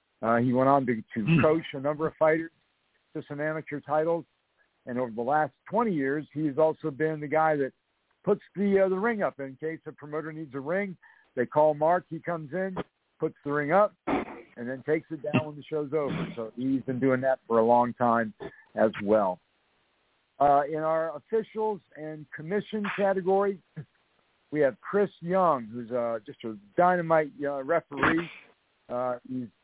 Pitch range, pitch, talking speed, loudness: 130-165 Hz, 155 Hz, 180 wpm, -28 LUFS